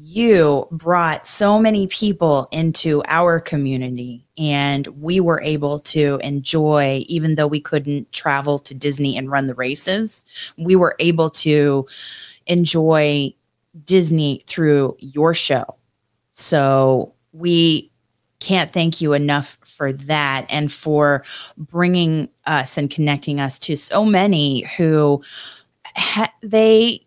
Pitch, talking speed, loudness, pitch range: 150 Hz, 120 wpm, -17 LUFS, 140-170 Hz